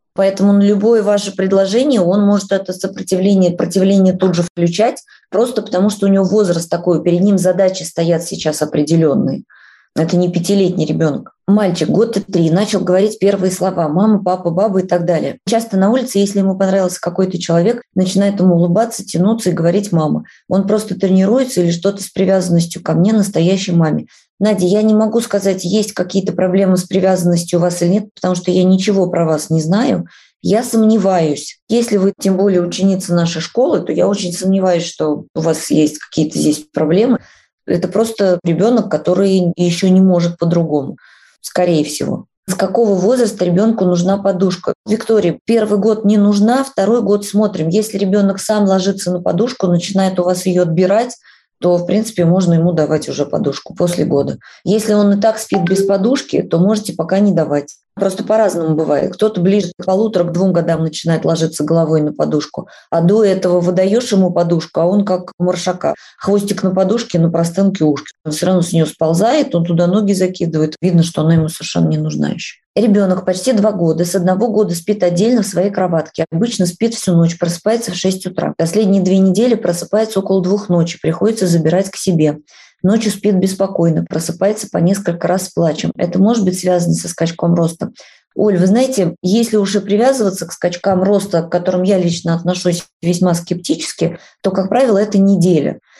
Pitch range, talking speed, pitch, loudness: 175-205 Hz, 180 wpm, 185 Hz, -14 LUFS